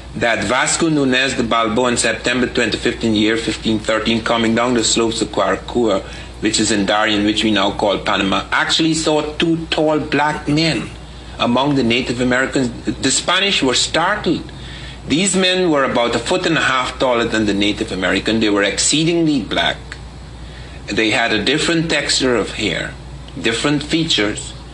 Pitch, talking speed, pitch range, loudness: 115 Hz, 165 wpm, 110-150 Hz, -16 LUFS